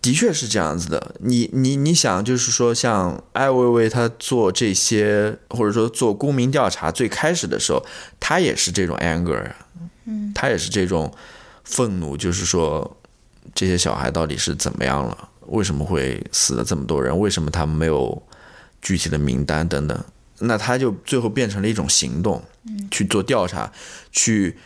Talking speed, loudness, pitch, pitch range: 265 characters per minute, -20 LUFS, 115 Hz, 90-130 Hz